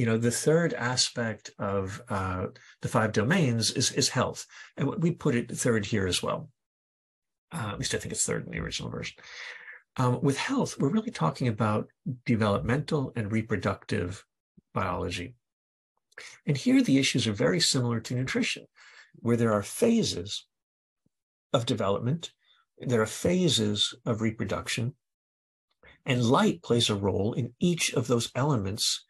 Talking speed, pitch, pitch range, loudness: 150 wpm, 120 Hz, 105-140 Hz, -28 LUFS